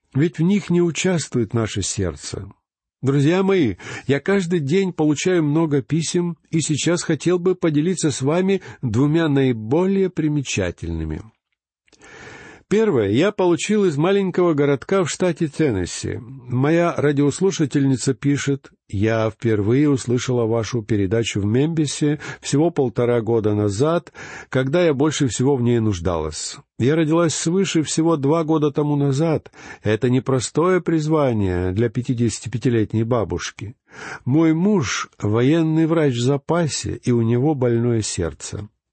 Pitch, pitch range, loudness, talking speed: 145 Hz, 120-165 Hz, -20 LUFS, 125 wpm